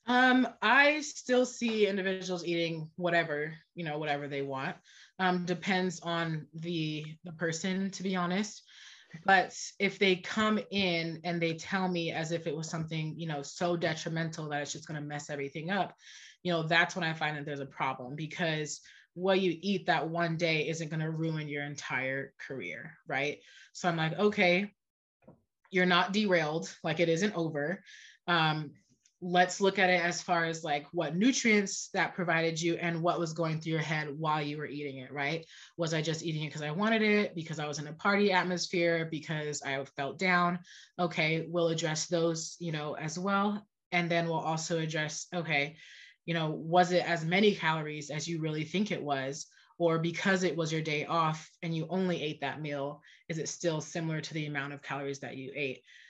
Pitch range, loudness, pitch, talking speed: 155-180 Hz, -31 LUFS, 165 Hz, 195 wpm